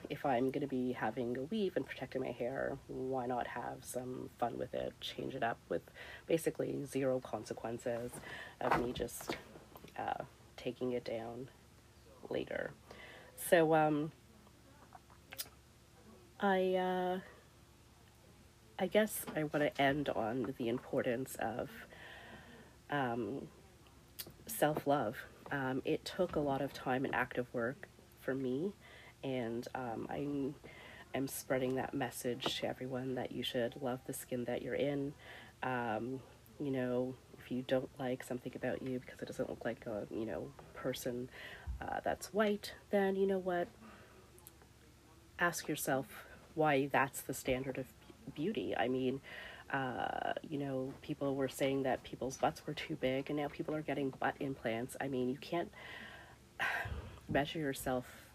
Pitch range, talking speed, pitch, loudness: 125-145 Hz, 145 wpm, 130 Hz, -39 LUFS